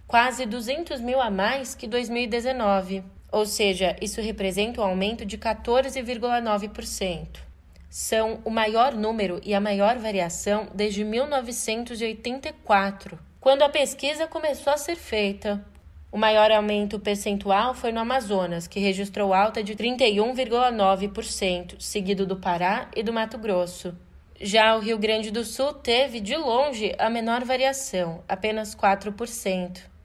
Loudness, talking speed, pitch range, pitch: -24 LUFS, 130 wpm, 195-240 Hz, 215 Hz